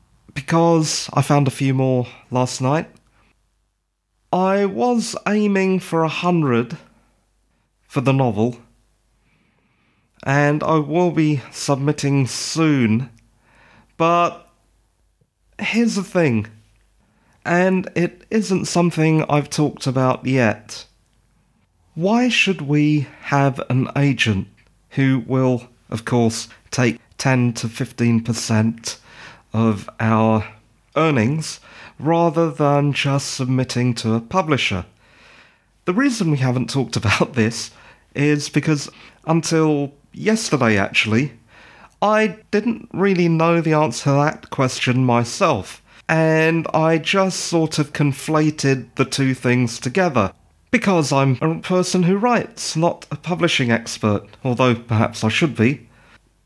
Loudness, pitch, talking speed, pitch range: -19 LUFS, 140 Hz, 115 wpm, 120-165 Hz